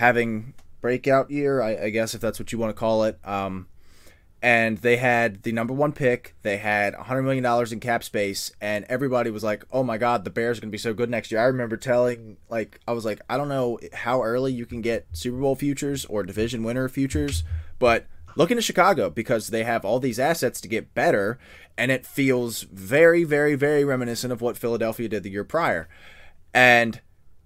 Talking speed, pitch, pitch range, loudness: 210 wpm, 115 Hz, 105-125 Hz, -23 LUFS